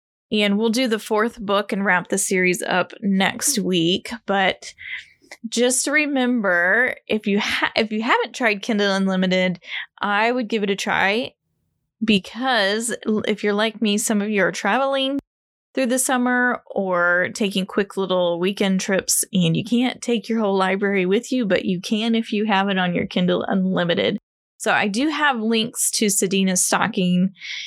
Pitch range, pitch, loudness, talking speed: 190-235 Hz, 210 Hz, -20 LUFS, 170 wpm